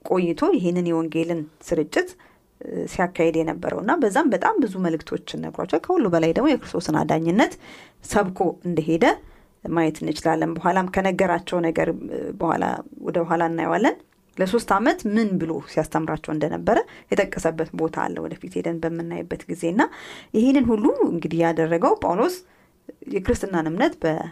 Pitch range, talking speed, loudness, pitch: 165-195 Hz, 120 wpm, -23 LUFS, 170 Hz